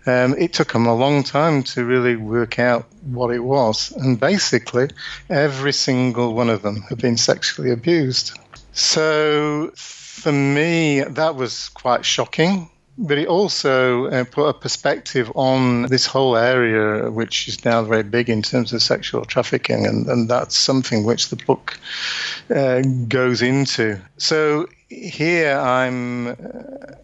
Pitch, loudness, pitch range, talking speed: 130 Hz, -18 LUFS, 120-145 Hz, 150 wpm